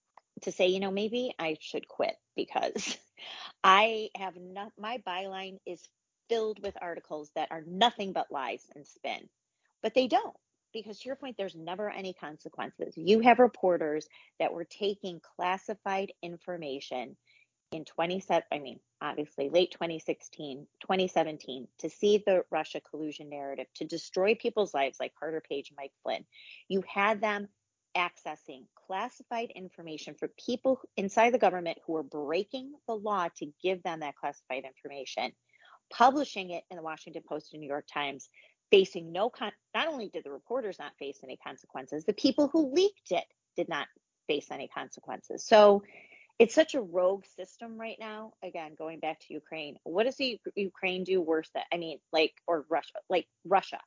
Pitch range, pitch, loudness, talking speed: 155-215 Hz, 185 Hz, -31 LUFS, 165 wpm